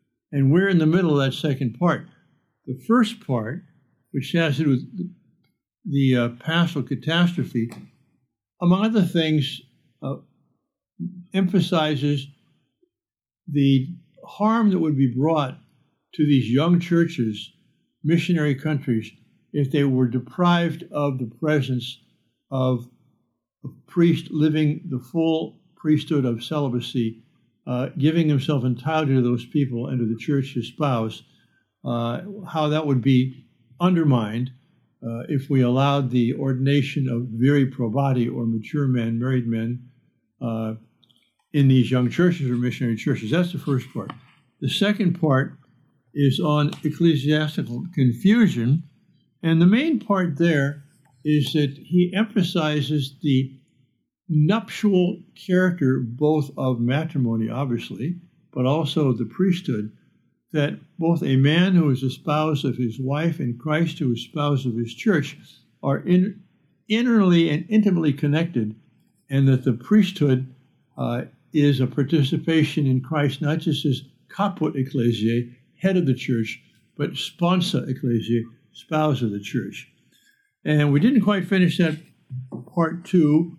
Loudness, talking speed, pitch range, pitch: -22 LUFS, 135 wpm, 130-165 Hz, 145 Hz